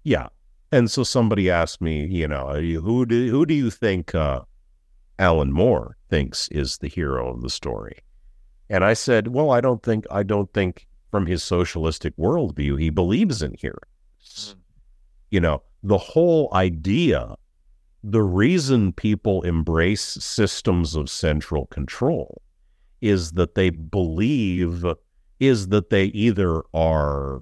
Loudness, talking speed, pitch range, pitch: -22 LUFS, 140 wpm, 80-105 Hz, 90 Hz